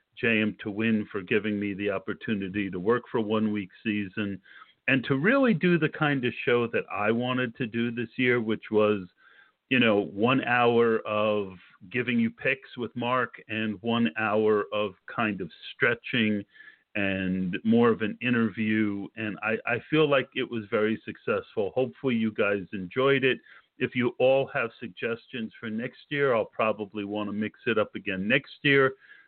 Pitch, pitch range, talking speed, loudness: 110 Hz, 105-125 Hz, 175 wpm, -27 LUFS